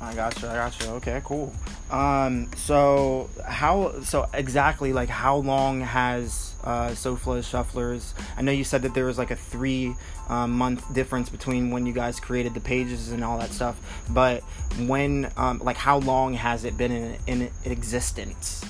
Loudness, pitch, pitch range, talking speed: -26 LUFS, 125 Hz, 120-130 Hz, 180 wpm